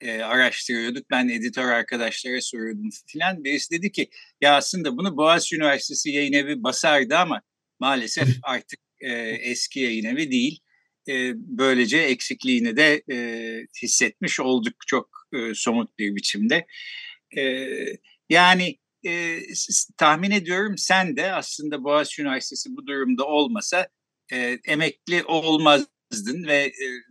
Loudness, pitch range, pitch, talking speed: -22 LUFS, 125-180 Hz, 145 Hz, 125 wpm